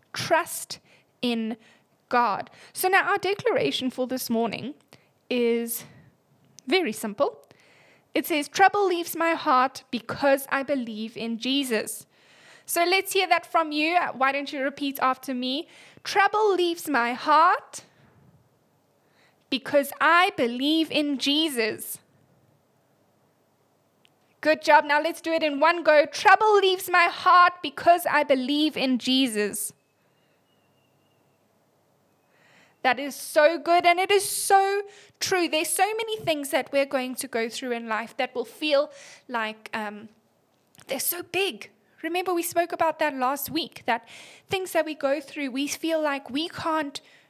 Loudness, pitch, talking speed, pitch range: -24 LUFS, 295 Hz, 140 wpm, 255-345 Hz